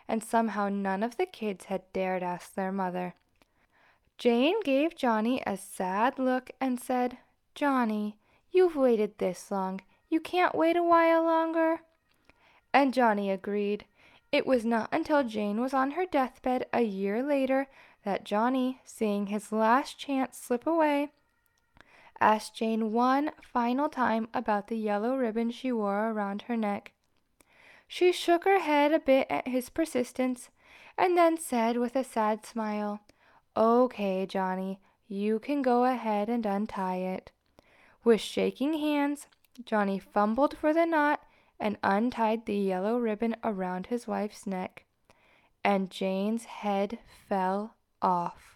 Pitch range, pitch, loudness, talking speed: 205-270 Hz, 235 Hz, -29 LUFS, 140 wpm